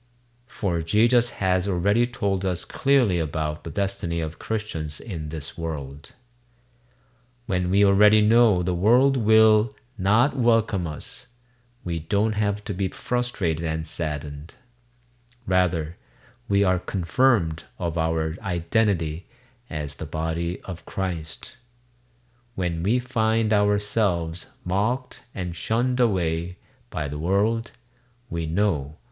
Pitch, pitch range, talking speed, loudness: 95 Hz, 80-120 Hz, 120 wpm, -24 LUFS